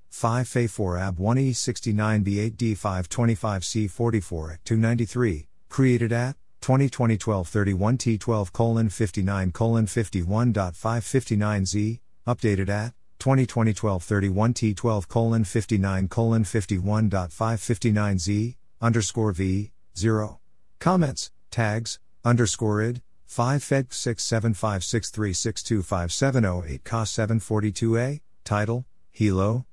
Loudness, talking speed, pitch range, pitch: -25 LUFS, 85 wpm, 100-115 Hz, 110 Hz